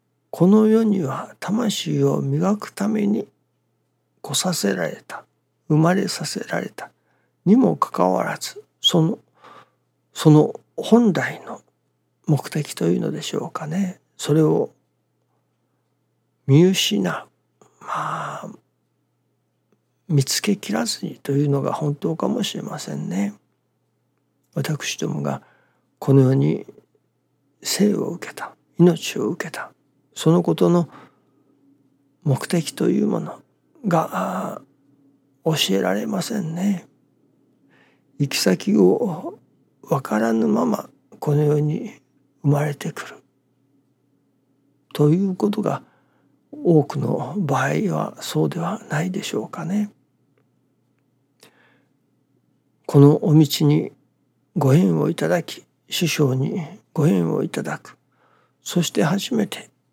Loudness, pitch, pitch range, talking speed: -21 LUFS, 150 Hz, 135-185 Hz, 195 characters per minute